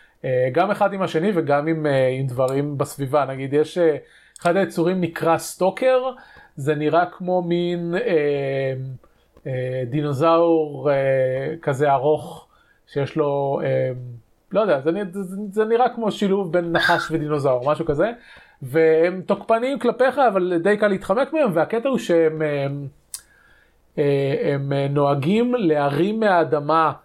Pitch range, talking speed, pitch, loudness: 140-190 Hz, 140 wpm, 160 Hz, -21 LUFS